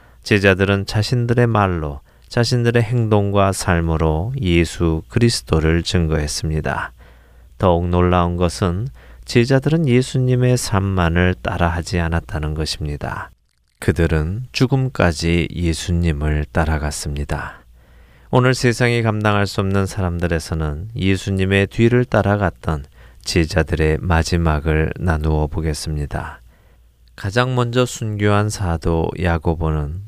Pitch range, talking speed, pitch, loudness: 80-105 Hz, 270 characters per minute, 85 Hz, -18 LUFS